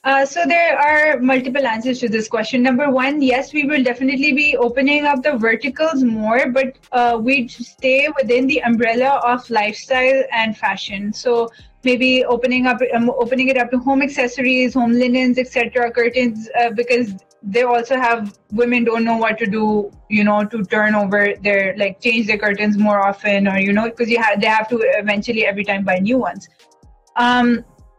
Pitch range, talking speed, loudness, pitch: 220-260 Hz, 185 wpm, -16 LUFS, 240 Hz